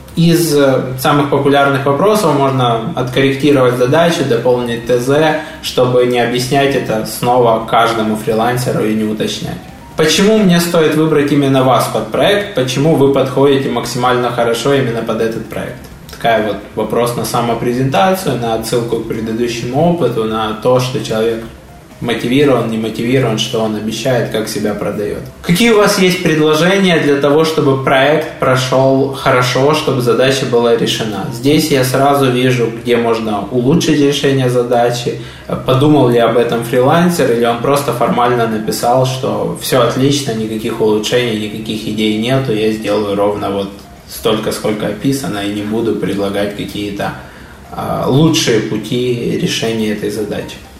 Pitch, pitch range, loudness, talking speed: 125 Hz, 115-145 Hz, -13 LUFS, 140 wpm